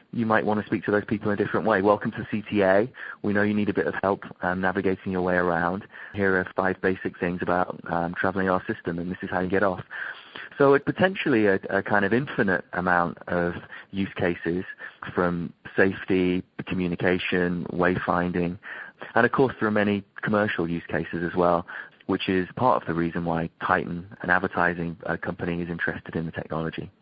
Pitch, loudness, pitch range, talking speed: 95 Hz, -25 LUFS, 85-105 Hz, 195 wpm